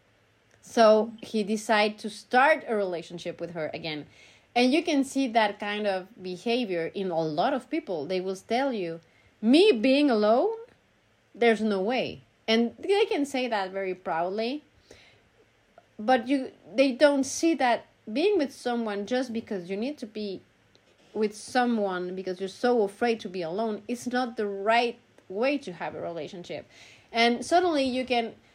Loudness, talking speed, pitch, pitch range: -27 LUFS, 160 wpm, 225 Hz, 190-255 Hz